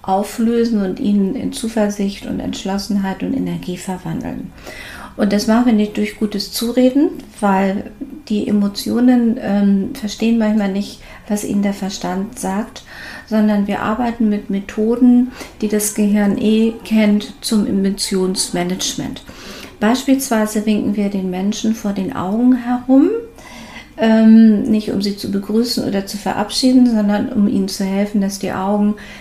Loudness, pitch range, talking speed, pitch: -16 LUFS, 200-230 Hz, 140 wpm, 210 Hz